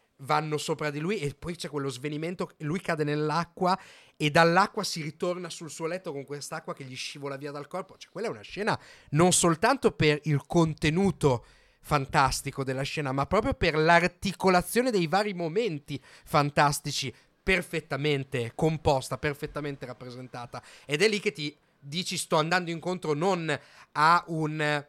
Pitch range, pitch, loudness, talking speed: 145-175 Hz, 155 Hz, -28 LUFS, 155 wpm